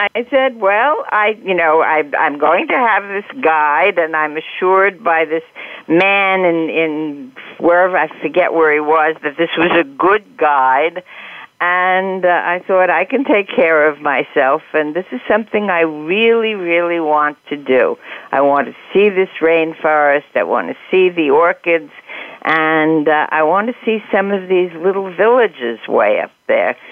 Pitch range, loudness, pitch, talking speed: 155-195 Hz, -14 LUFS, 170 Hz, 175 wpm